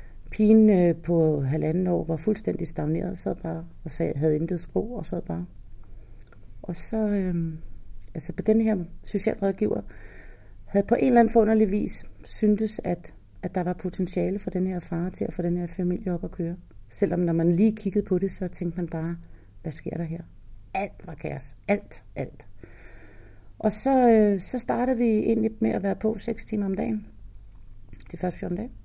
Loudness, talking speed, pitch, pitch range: -26 LUFS, 190 wpm, 180 Hz, 160-210 Hz